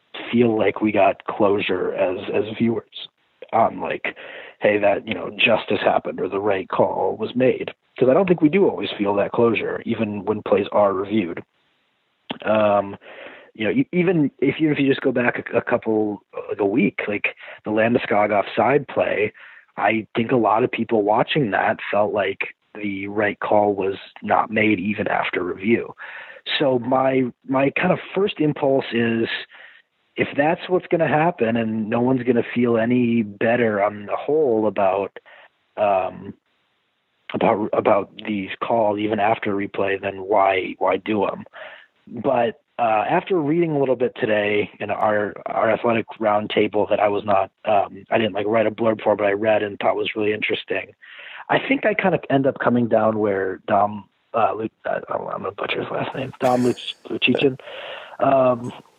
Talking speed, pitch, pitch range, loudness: 180 wpm, 115 Hz, 105-135 Hz, -21 LUFS